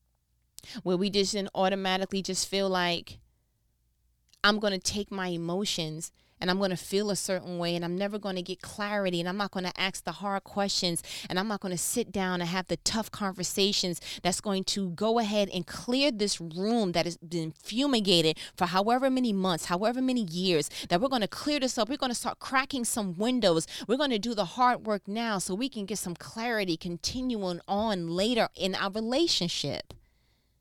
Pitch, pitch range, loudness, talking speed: 195 Hz, 175-215 Hz, -29 LUFS, 190 wpm